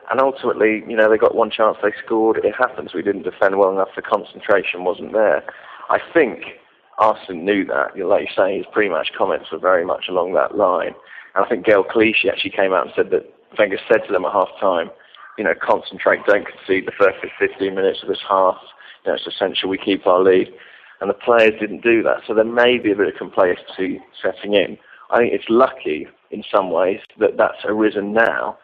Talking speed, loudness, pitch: 220 wpm, -18 LUFS, 115 Hz